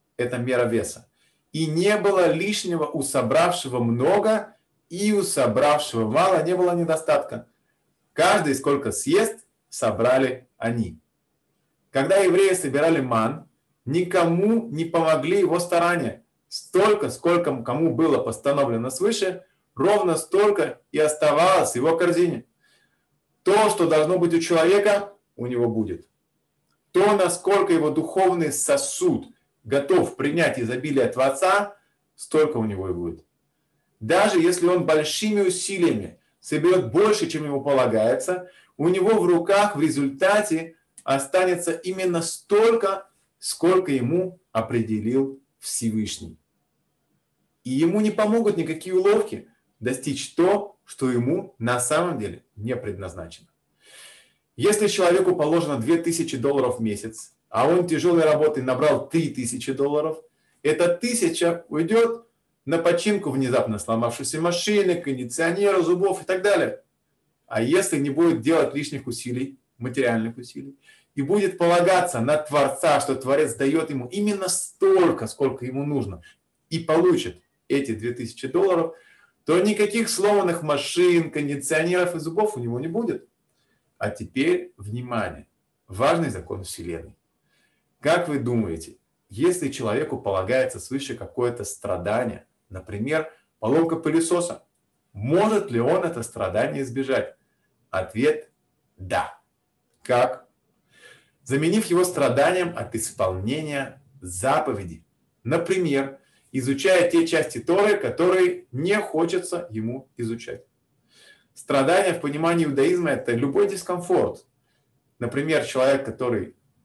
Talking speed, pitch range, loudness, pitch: 115 wpm, 130-185 Hz, -22 LUFS, 160 Hz